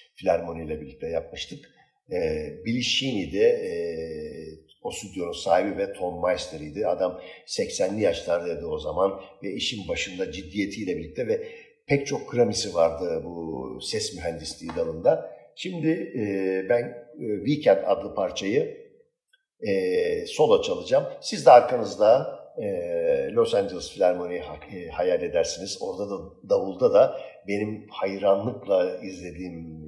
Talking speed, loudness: 120 wpm, -25 LUFS